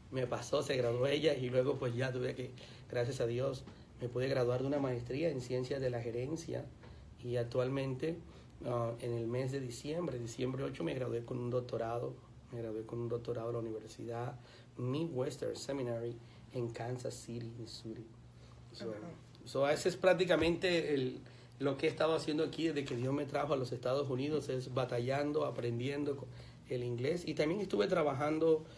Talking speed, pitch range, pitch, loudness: 175 wpm, 120-145 Hz, 125 Hz, -37 LUFS